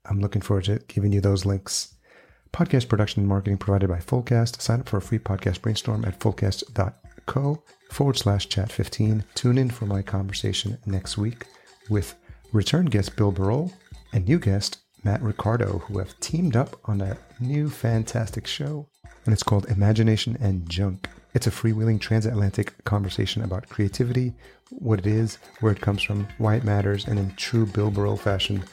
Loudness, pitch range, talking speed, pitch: -25 LUFS, 100-115 Hz, 175 wpm, 105 Hz